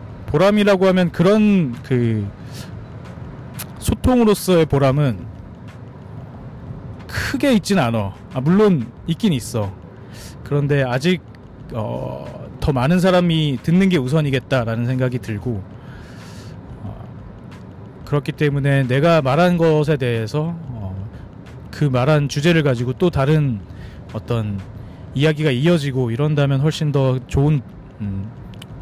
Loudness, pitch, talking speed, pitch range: -18 LUFS, 135 Hz, 225 characters per minute, 115-155 Hz